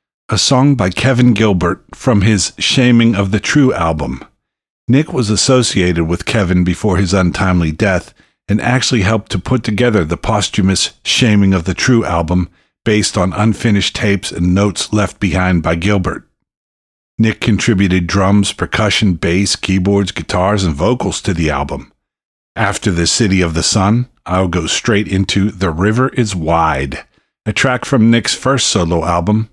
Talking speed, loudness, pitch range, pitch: 155 wpm, -13 LUFS, 90-110 Hz, 100 Hz